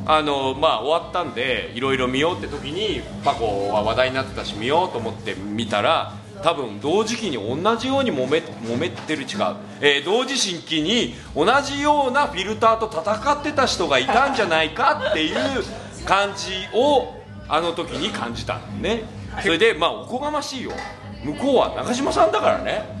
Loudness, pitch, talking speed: -21 LUFS, 160 Hz, 345 characters per minute